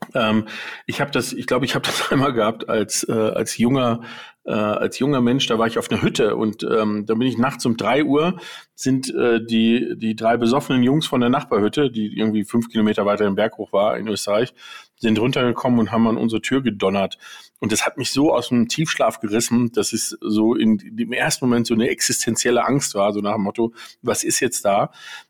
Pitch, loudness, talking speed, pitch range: 115 Hz, -20 LUFS, 220 wpm, 110-125 Hz